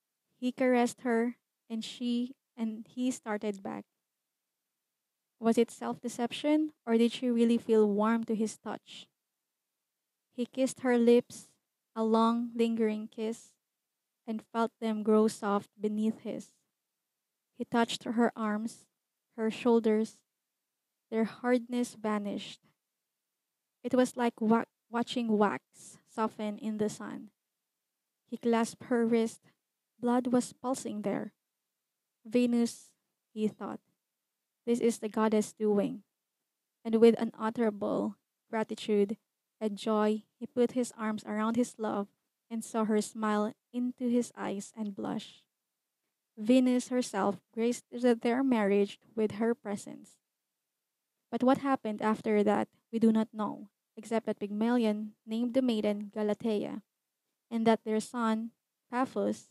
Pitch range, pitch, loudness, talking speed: 215-240 Hz, 225 Hz, -31 LUFS, 125 wpm